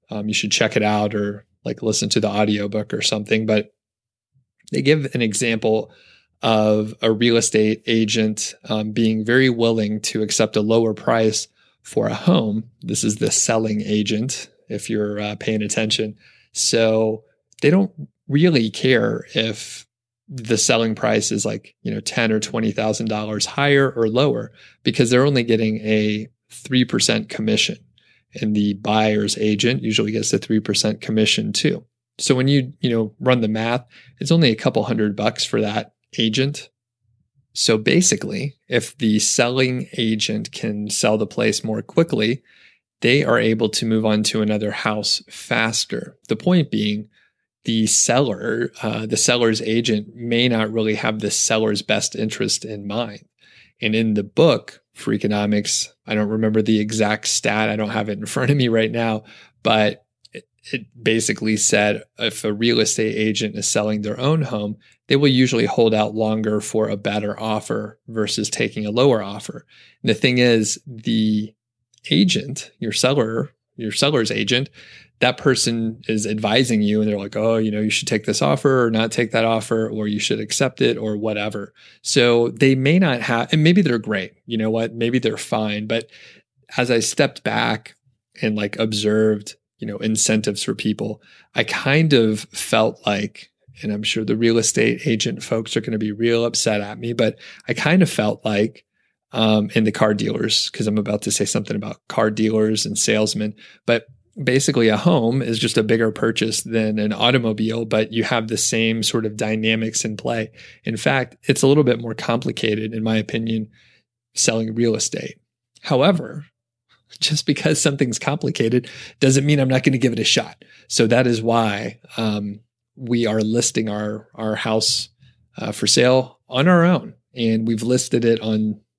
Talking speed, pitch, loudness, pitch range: 175 wpm, 110 Hz, -19 LUFS, 105-120 Hz